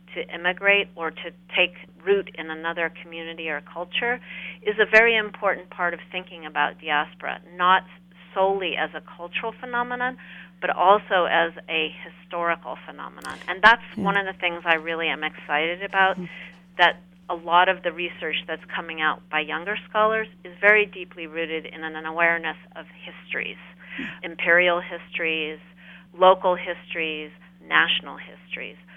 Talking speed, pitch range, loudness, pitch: 145 wpm, 165-190 Hz, -23 LUFS, 180 Hz